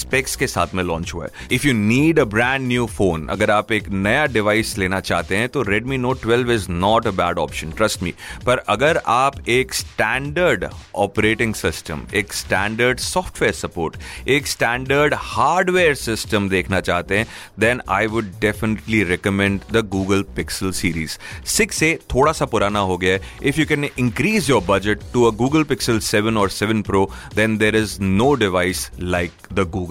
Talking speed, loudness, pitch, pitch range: 175 wpm, -19 LUFS, 105 Hz, 95-120 Hz